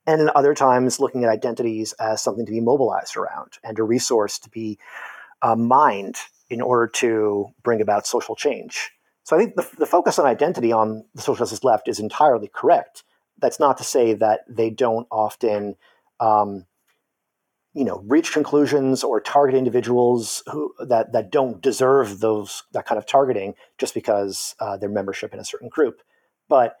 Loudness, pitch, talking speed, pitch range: -20 LUFS, 115 Hz, 175 wpm, 110-130 Hz